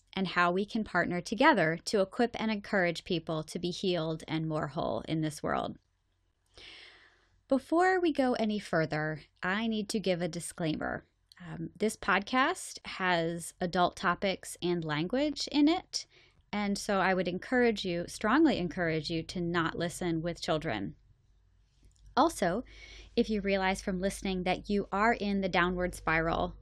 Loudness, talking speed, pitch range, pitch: -31 LUFS, 155 wpm, 165-210 Hz, 180 Hz